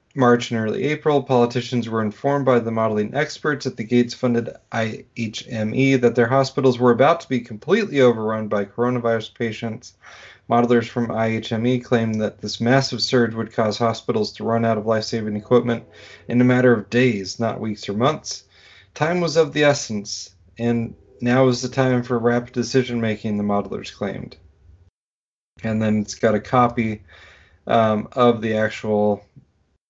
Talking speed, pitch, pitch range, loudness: 165 wpm, 115 Hz, 110-125 Hz, -20 LUFS